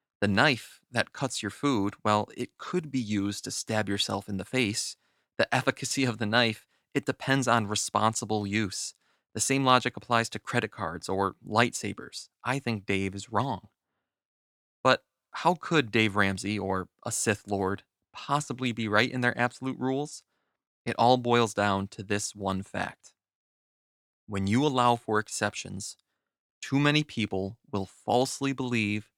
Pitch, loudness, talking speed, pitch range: 110 Hz, -28 LUFS, 155 wpm, 100-125 Hz